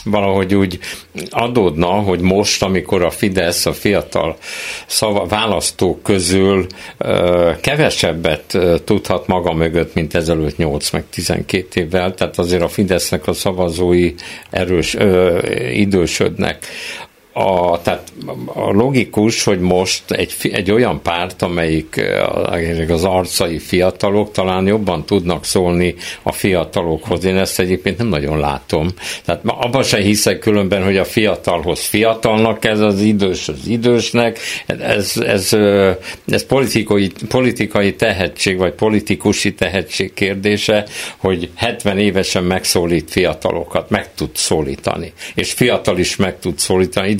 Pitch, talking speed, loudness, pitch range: 95 Hz, 125 wpm, -15 LUFS, 90-105 Hz